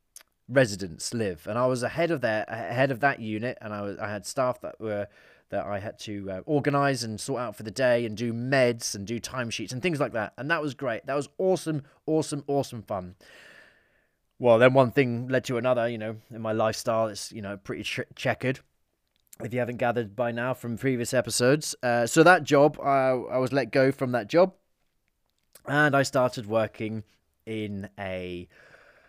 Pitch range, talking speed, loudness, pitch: 110-135 Hz, 200 wpm, -26 LUFS, 120 Hz